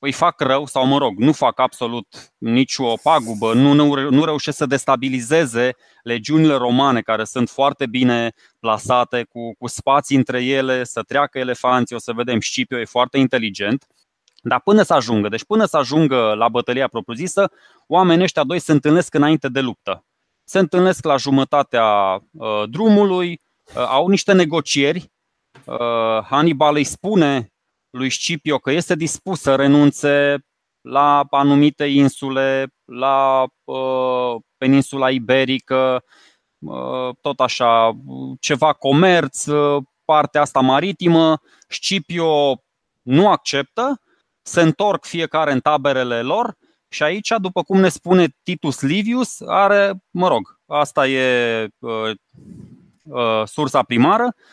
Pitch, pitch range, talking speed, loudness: 140 Hz, 125-160 Hz, 130 wpm, -17 LUFS